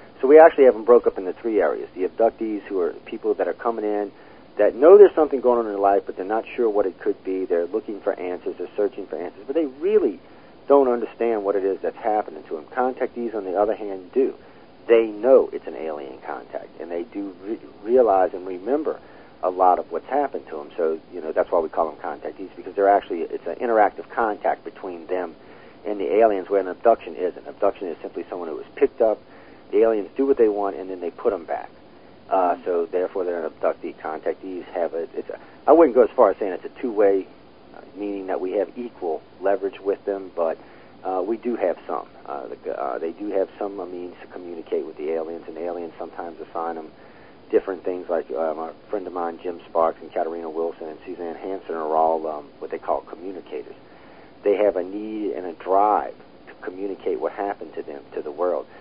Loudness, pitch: -22 LUFS, 120 Hz